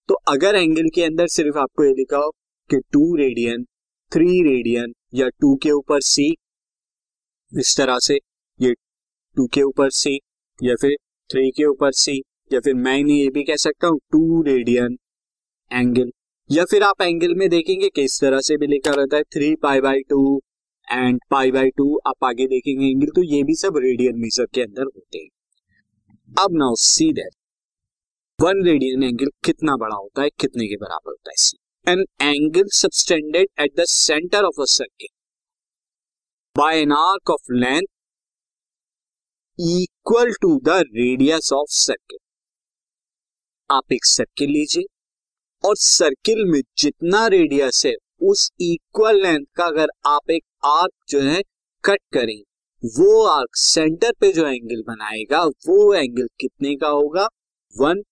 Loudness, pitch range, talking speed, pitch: -18 LUFS, 130-190 Hz, 160 wpm, 145 Hz